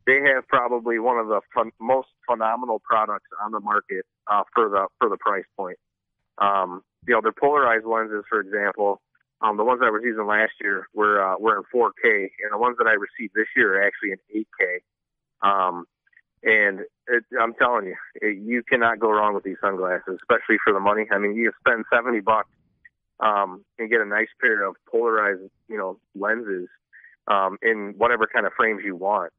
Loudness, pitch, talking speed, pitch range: -22 LUFS, 110 Hz, 195 wpm, 100-120 Hz